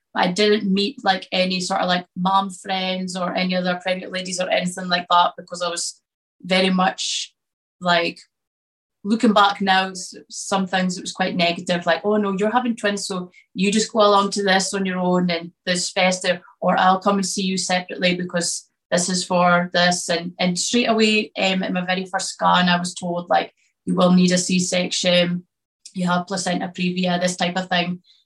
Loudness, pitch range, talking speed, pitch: -20 LUFS, 180-195 Hz, 195 wpm, 185 Hz